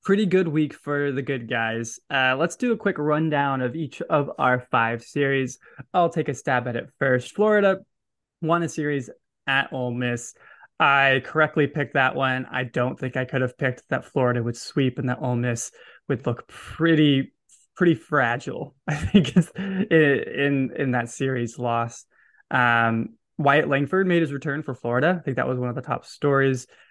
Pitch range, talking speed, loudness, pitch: 125-155 Hz, 185 wpm, -23 LUFS, 135 Hz